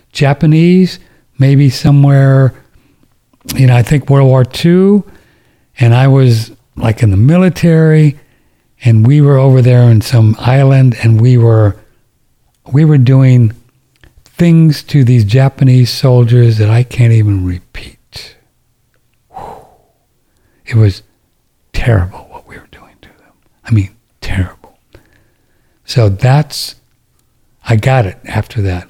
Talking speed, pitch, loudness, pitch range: 125 wpm, 125 Hz, -9 LUFS, 110-135 Hz